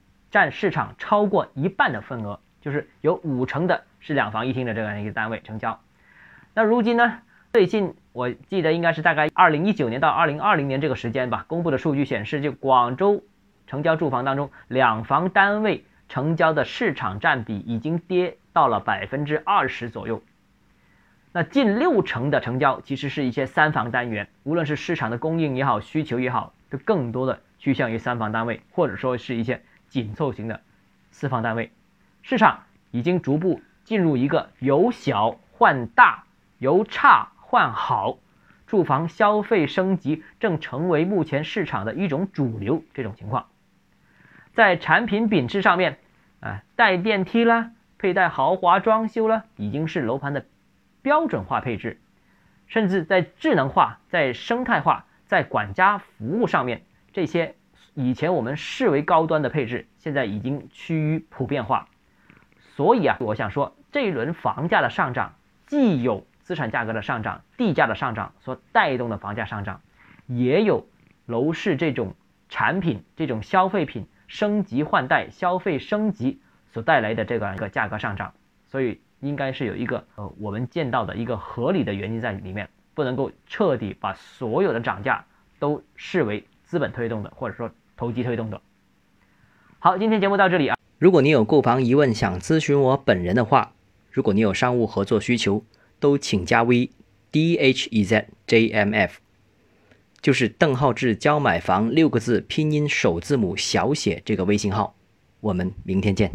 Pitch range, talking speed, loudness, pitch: 115-175 Hz, 260 characters per minute, -22 LUFS, 140 Hz